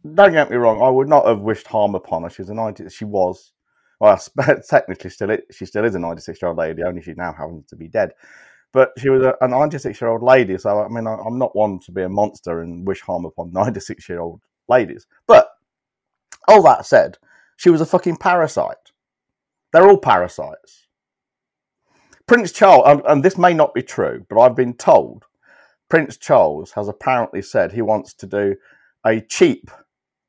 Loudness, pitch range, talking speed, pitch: -16 LUFS, 95-145 Hz, 200 wpm, 110 Hz